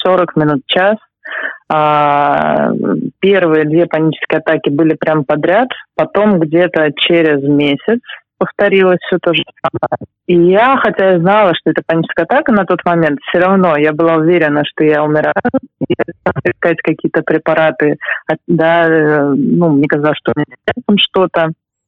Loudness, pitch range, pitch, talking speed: -12 LUFS, 150-180 Hz, 165 Hz, 150 wpm